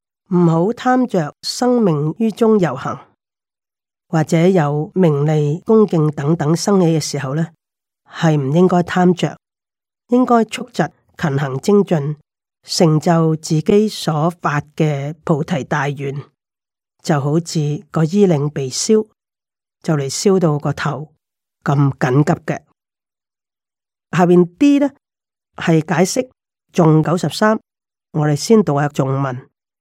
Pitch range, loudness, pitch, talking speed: 150-185 Hz, -16 LUFS, 165 Hz, 175 characters per minute